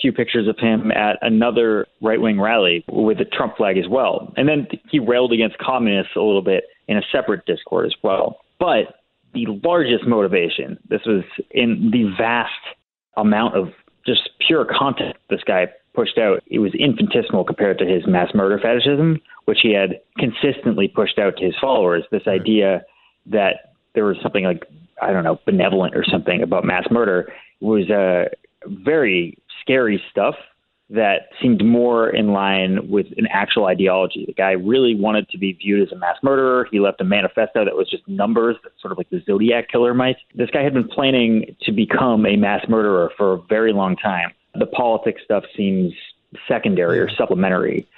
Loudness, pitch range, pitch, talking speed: -18 LUFS, 100-130 Hz, 115 Hz, 185 wpm